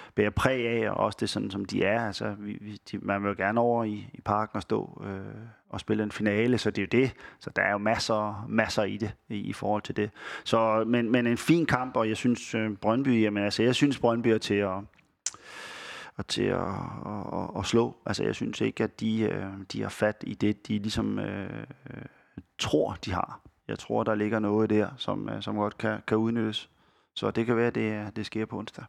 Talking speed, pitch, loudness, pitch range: 235 wpm, 110 Hz, -29 LUFS, 105-115 Hz